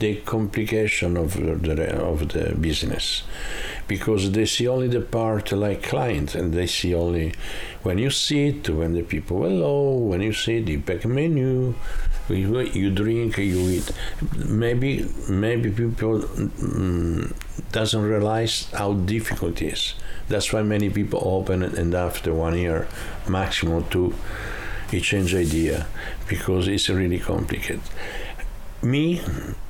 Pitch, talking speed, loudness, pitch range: 100 Hz, 135 wpm, -24 LUFS, 90-110 Hz